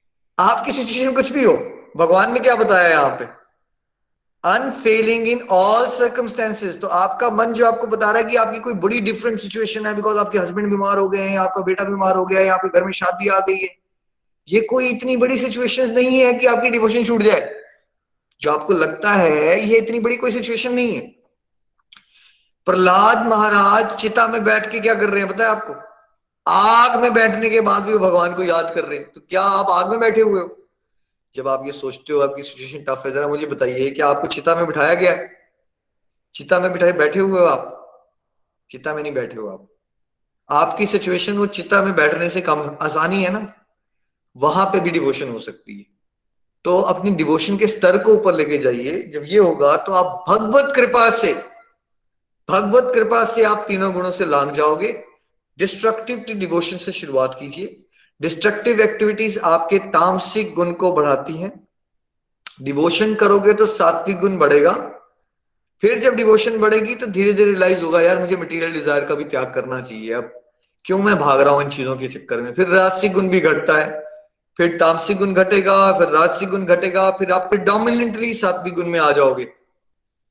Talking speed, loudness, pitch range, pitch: 165 wpm, -17 LUFS, 170-225 Hz, 195 Hz